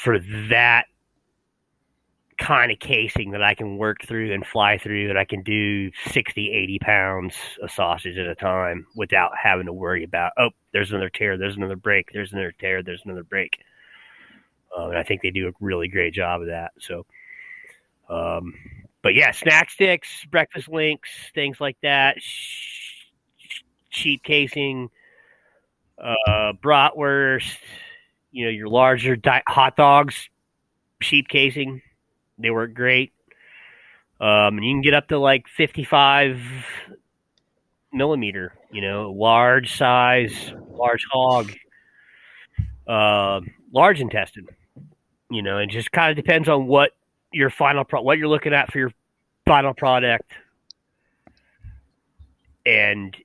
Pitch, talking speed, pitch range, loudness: 120 Hz, 135 wpm, 105-140 Hz, -19 LUFS